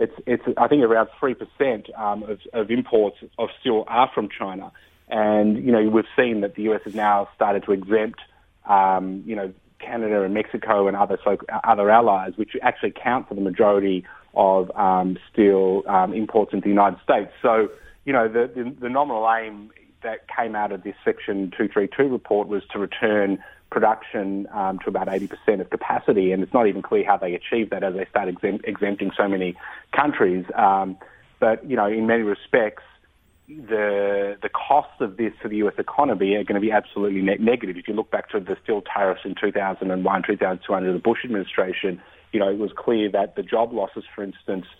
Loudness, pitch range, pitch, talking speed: -22 LUFS, 95-110 Hz, 105 Hz, 200 wpm